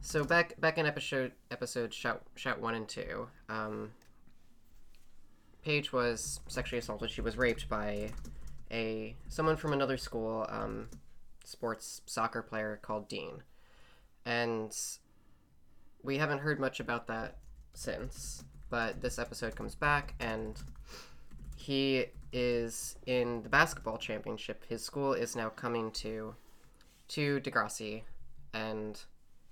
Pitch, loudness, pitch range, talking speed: 115 Hz, -36 LUFS, 105-125 Hz, 120 wpm